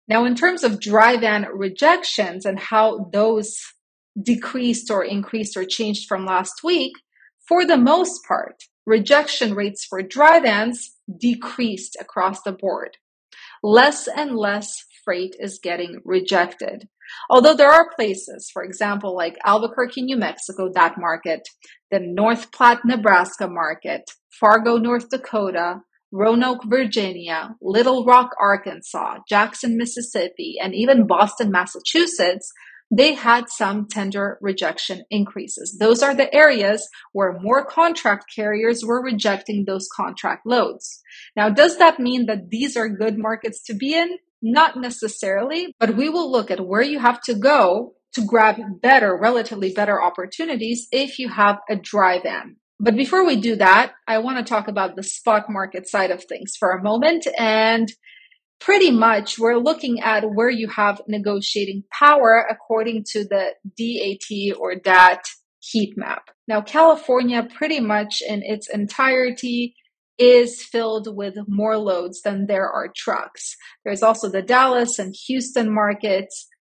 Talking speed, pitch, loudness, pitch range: 145 wpm, 220 Hz, -18 LUFS, 200-245 Hz